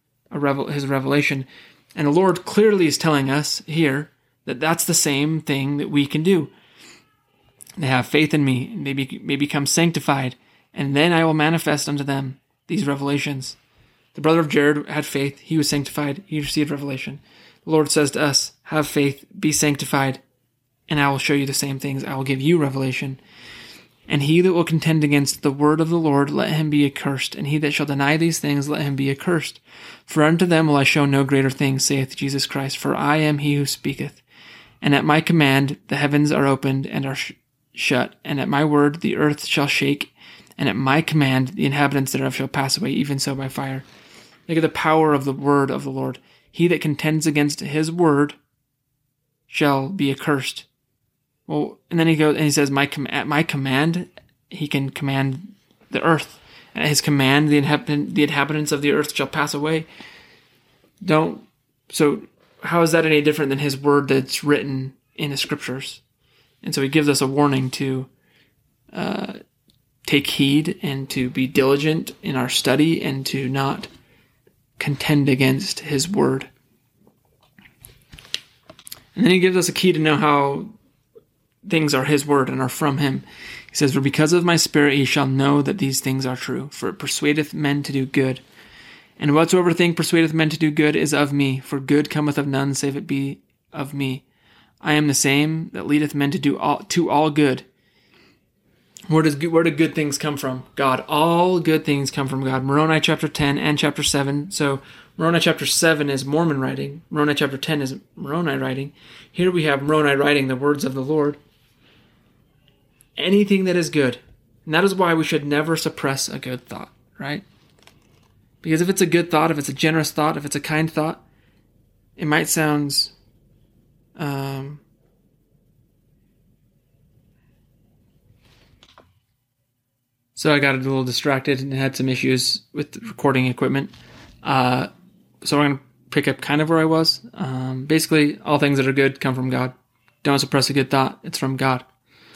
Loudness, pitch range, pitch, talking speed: -20 LUFS, 135-155 Hz, 145 Hz, 185 wpm